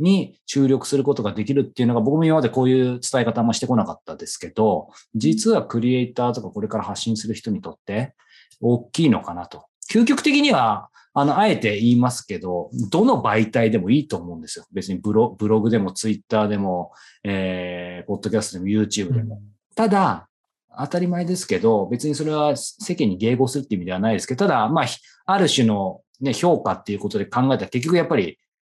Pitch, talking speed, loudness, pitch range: 120 Hz, 415 characters per minute, -21 LUFS, 105-150 Hz